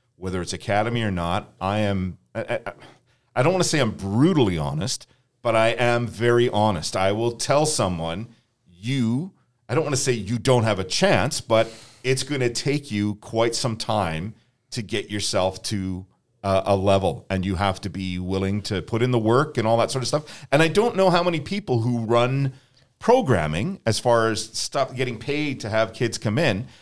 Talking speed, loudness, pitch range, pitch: 205 wpm, -23 LUFS, 105-130 Hz, 115 Hz